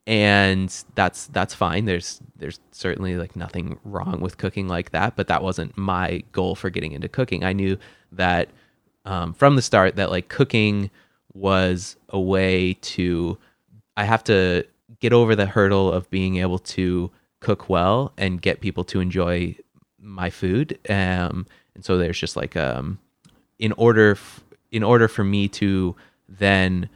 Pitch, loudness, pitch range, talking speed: 95 Hz, -22 LUFS, 90-105 Hz, 160 wpm